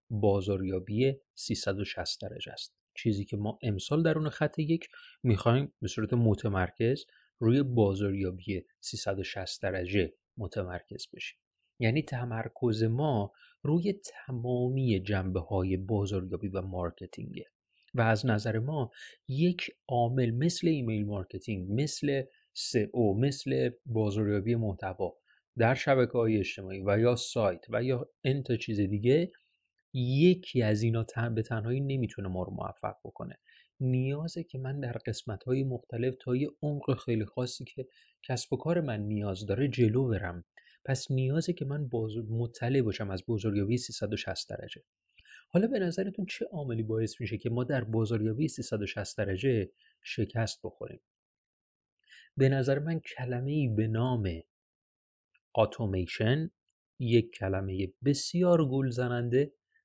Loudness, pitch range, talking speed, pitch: -31 LUFS, 105-135 Hz, 130 wpm, 120 Hz